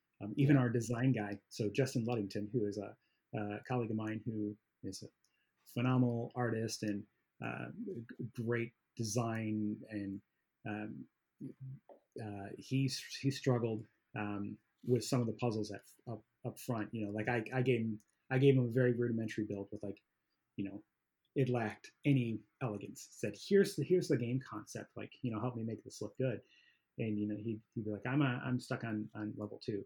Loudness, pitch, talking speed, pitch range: -38 LUFS, 115 Hz, 190 wpm, 105-125 Hz